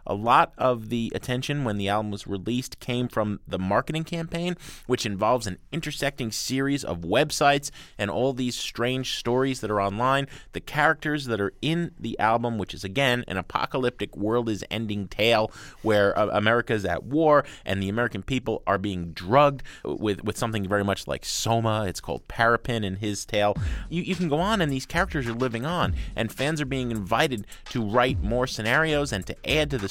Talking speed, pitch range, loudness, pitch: 195 wpm, 105-140 Hz, -25 LUFS, 120 Hz